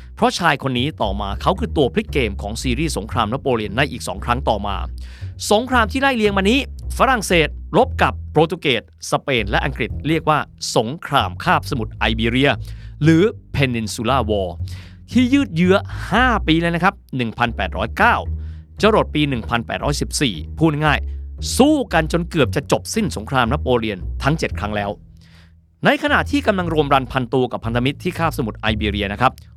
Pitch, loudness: 120 Hz, -19 LUFS